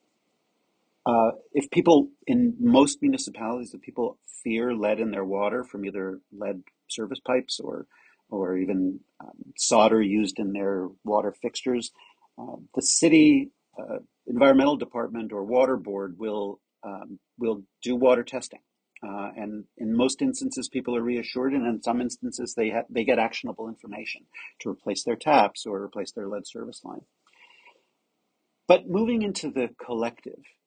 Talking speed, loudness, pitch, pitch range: 150 wpm, -25 LUFS, 120 Hz, 105-155 Hz